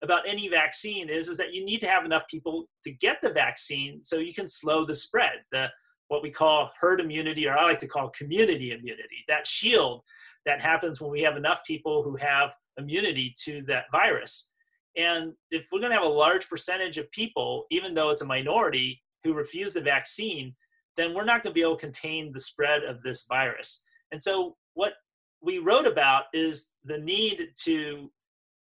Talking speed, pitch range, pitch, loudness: 195 wpm, 150-205 Hz, 160 Hz, -26 LUFS